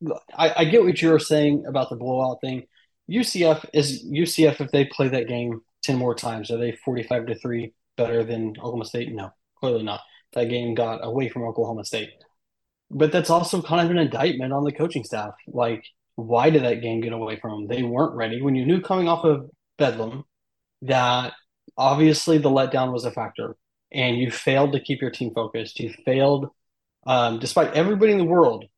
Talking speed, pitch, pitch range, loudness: 195 wpm, 130 Hz, 120-155 Hz, -22 LUFS